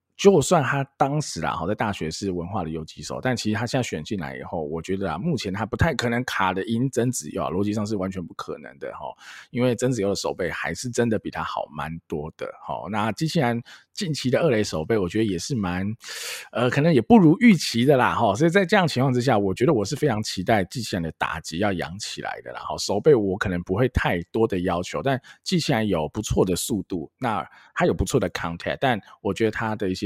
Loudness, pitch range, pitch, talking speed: -24 LUFS, 95-130 Hz, 110 Hz, 355 characters per minute